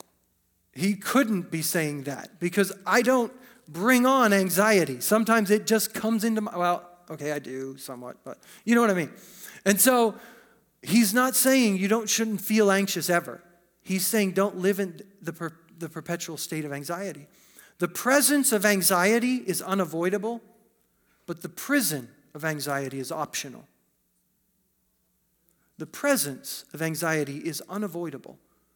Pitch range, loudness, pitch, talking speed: 160-220 Hz, -25 LUFS, 190 Hz, 145 wpm